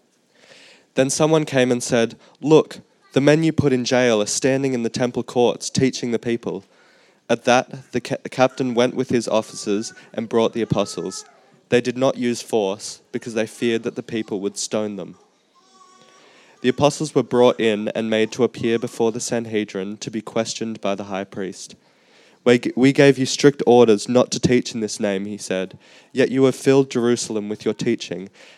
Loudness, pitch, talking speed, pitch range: -20 LUFS, 120 Hz, 185 wpm, 110-130 Hz